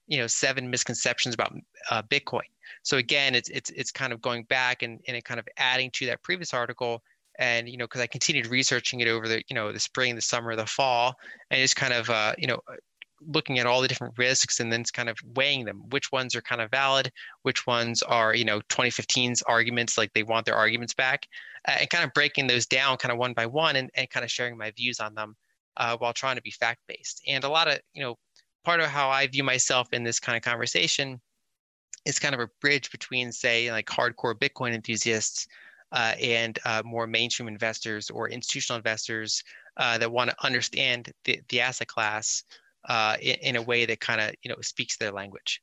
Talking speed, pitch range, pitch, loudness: 220 wpm, 115-130 Hz, 120 Hz, -26 LUFS